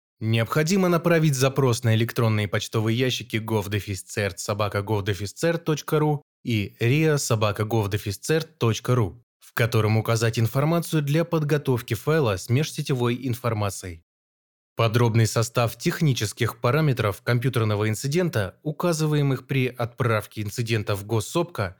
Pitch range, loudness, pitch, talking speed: 110-145 Hz, -24 LUFS, 120 Hz, 90 wpm